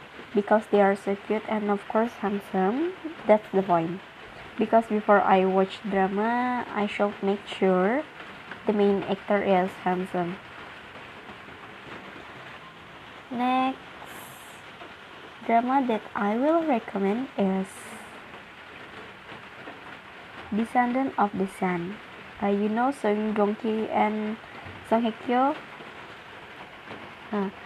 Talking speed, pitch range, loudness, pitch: 100 wpm, 195-230 Hz, -26 LUFS, 210 Hz